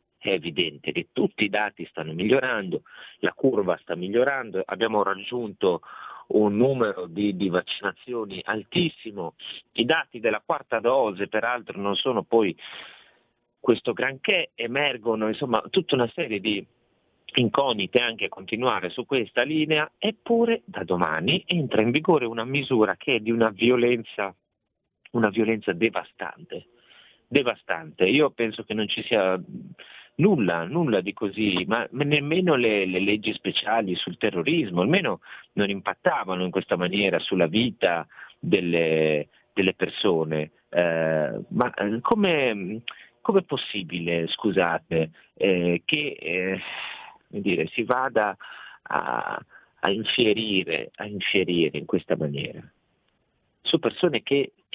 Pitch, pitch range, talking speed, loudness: 105 Hz, 95-120 Hz, 125 wpm, -25 LUFS